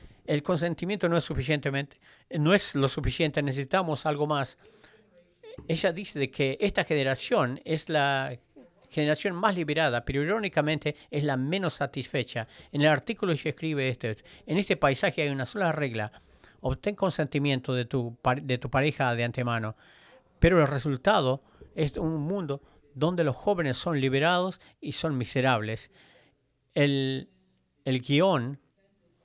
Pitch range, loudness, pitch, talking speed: 130-165 Hz, -28 LUFS, 145 Hz, 140 wpm